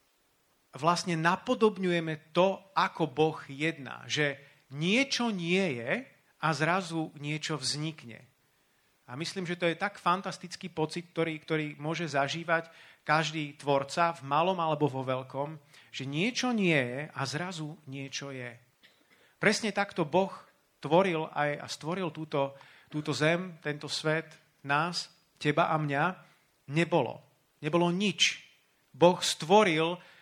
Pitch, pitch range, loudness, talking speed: 160 Hz, 145-175 Hz, -30 LUFS, 125 wpm